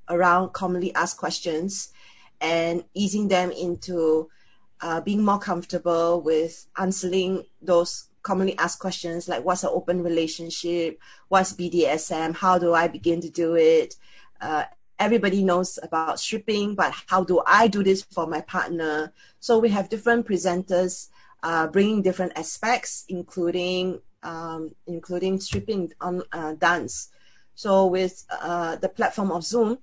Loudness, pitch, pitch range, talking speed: -24 LUFS, 180 Hz, 170-190 Hz, 140 wpm